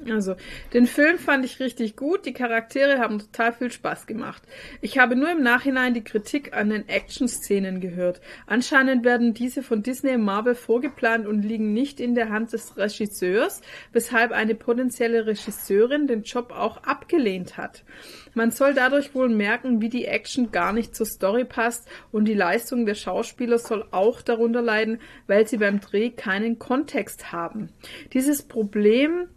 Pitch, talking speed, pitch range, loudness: 235 Hz, 165 wpm, 215-255 Hz, -23 LUFS